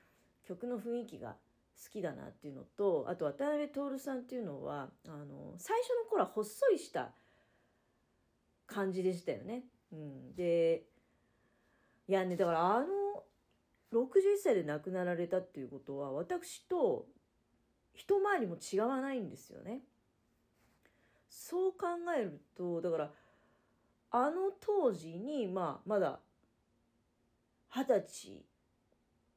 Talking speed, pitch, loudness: 225 characters per minute, 230 Hz, -36 LUFS